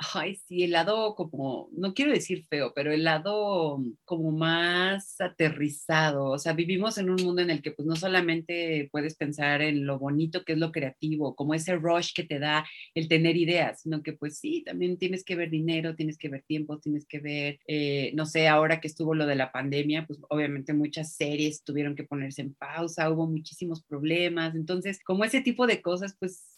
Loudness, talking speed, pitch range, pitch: -28 LUFS, 205 wpm, 150-175 Hz, 160 Hz